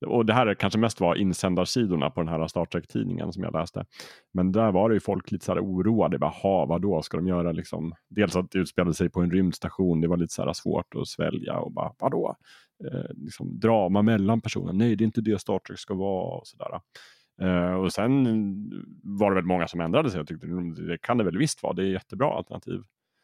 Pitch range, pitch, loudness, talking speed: 85-110 Hz, 95 Hz, -26 LUFS, 225 wpm